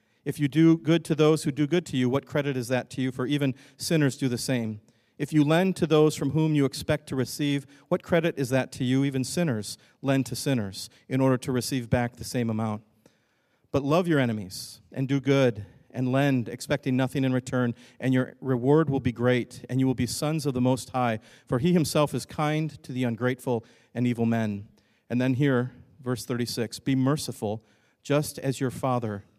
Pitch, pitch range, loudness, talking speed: 130 Hz, 120-145 Hz, -26 LUFS, 210 wpm